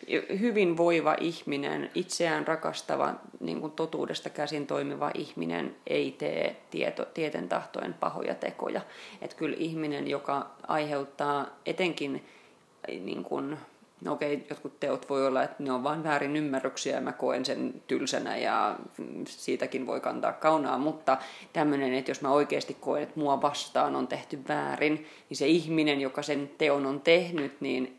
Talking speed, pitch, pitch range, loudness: 150 wpm, 145 Hz, 140-155 Hz, -30 LUFS